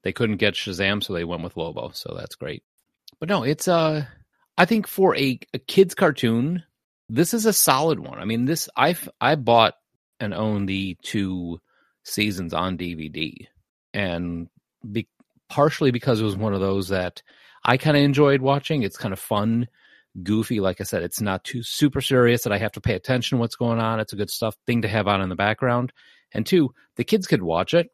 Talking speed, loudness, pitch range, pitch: 210 wpm, -22 LUFS, 100-140 Hz, 115 Hz